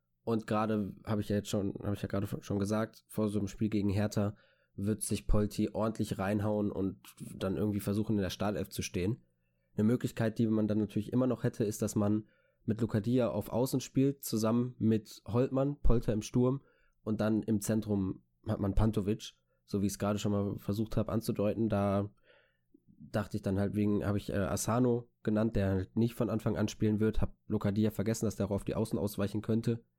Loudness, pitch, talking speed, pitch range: -33 LUFS, 105 Hz, 200 wpm, 100-110 Hz